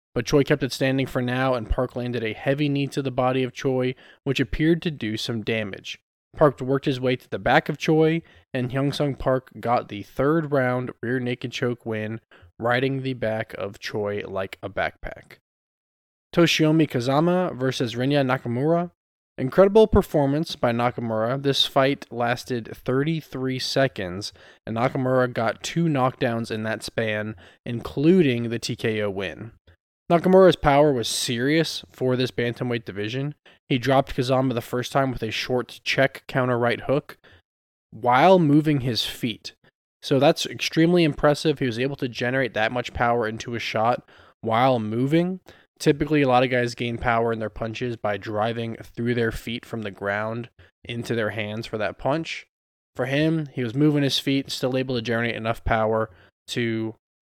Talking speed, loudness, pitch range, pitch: 165 wpm, -23 LUFS, 115-140 Hz, 125 Hz